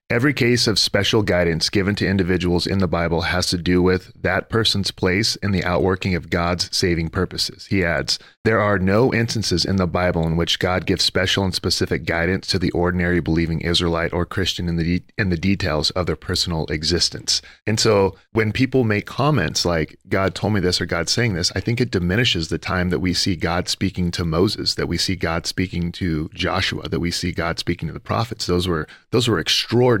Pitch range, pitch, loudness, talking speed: 85-100 Hz, 90 Hz, -20 LUFS, 215 wpm